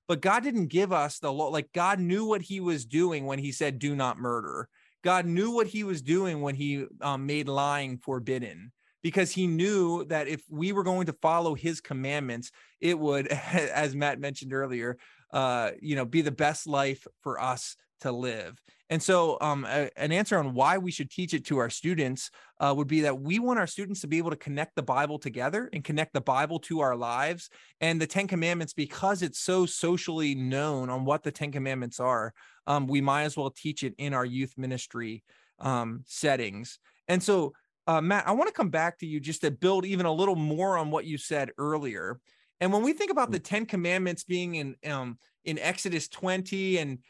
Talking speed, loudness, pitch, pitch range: 210 wpm, -29 LUFS, 155 Hz, 140-180 Hz